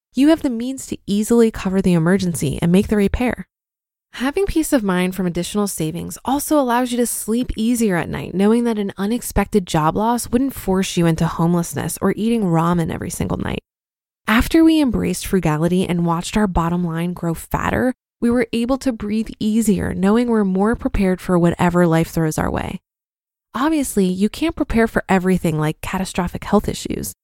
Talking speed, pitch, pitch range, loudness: 180 wpm, 200 Hz, 175-235 Hz, -19 LUFS